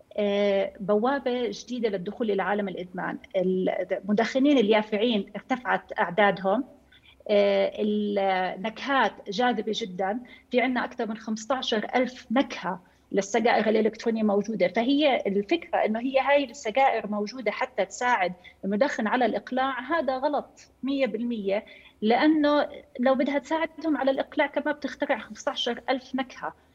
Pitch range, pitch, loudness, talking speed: 205-270 Hz, 235 Hz, -26 LUFS, 110 wpm